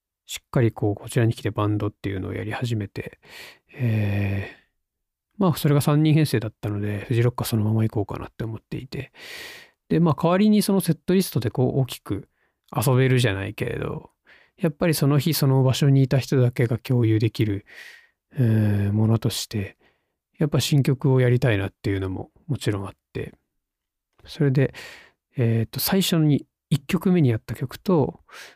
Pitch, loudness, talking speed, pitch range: 125 Hz, -23 LUFS, 340 characters per minute, 105-145 Hz